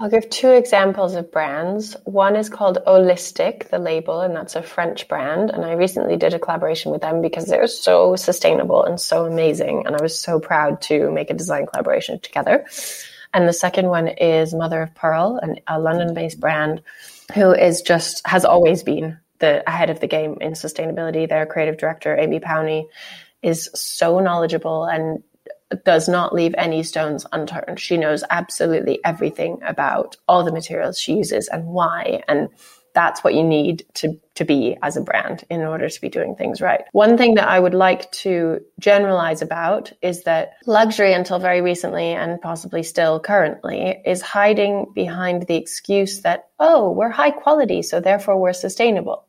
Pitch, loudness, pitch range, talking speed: 170 Hz, -18 LUFS, 160-195 Hz, 180 wpm